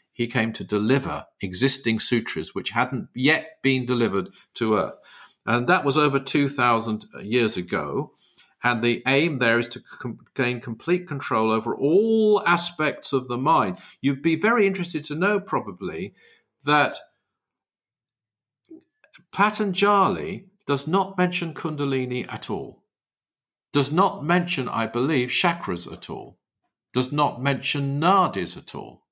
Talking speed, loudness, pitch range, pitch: 135 wpm, -23 LUFS, 120-175 Hz, 140 Hz